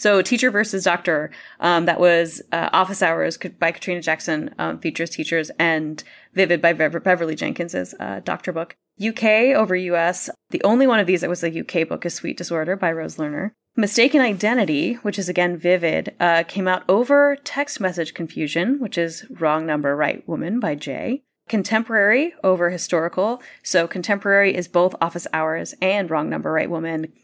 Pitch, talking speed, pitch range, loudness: 180 Hz, 170 wpm, 165-210 Hz, -20 LUFS